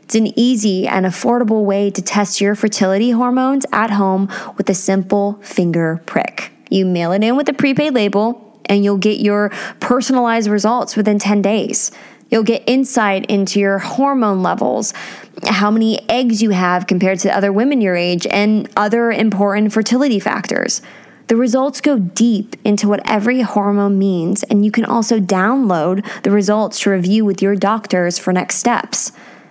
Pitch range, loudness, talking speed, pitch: 195-230 Hz, -15 LUFS, 165 wpm, 210 Hz